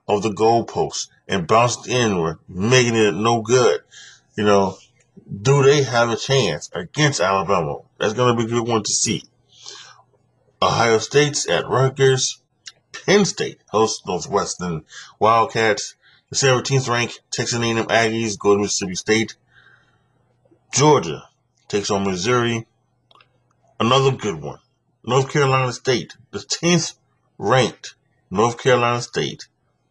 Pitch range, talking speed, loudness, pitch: 105-130 Hz, 125 wpm, -19 LUFS, 120 Hz